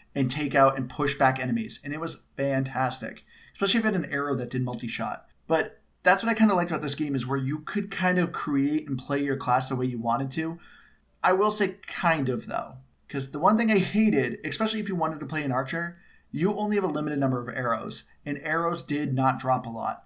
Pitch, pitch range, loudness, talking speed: 145 Hz, 130-175 Hz, -26 LUFS, 240 wpm